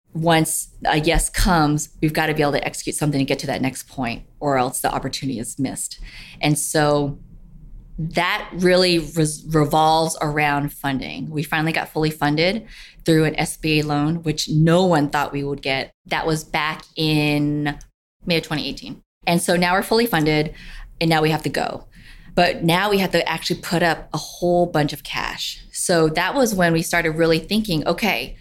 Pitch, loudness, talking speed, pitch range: 155 Hz, -20 LUFS, 190 wpm, 150-170 Hz